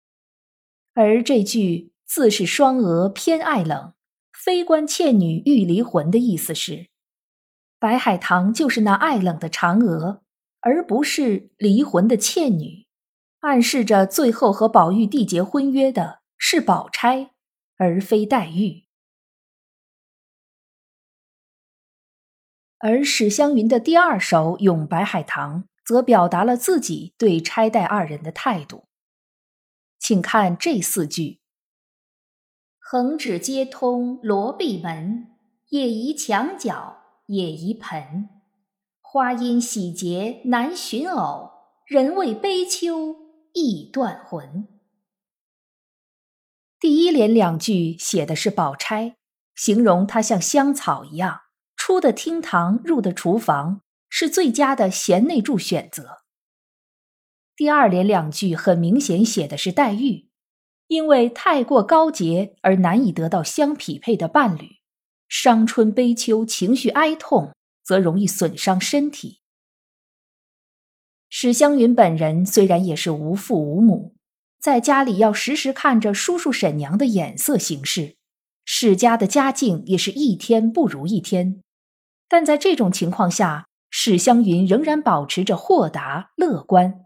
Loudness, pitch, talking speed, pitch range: -19 LUFS, 220 Hz, 180 characters per minute, 185-270 Hz